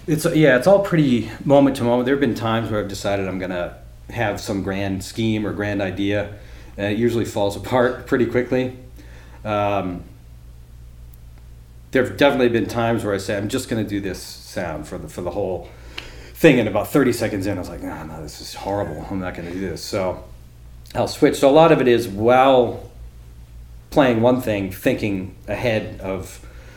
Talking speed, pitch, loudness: 195 wpm, 100 Hz, -20 LUFS